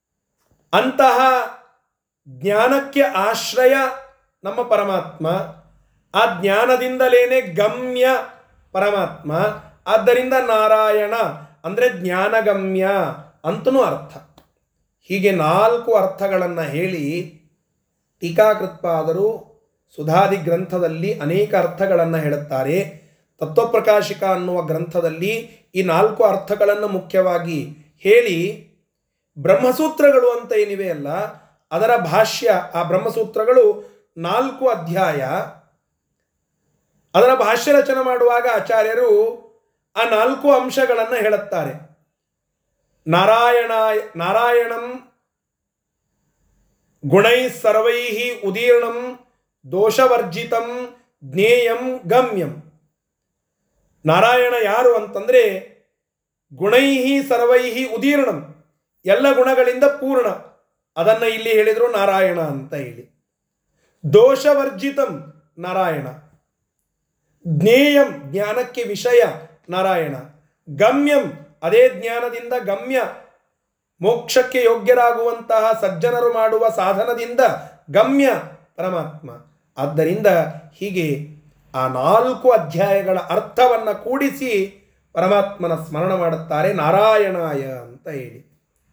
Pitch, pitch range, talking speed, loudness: 215 Hz, 175-245 Hz, 70 wpm, -17 LUFS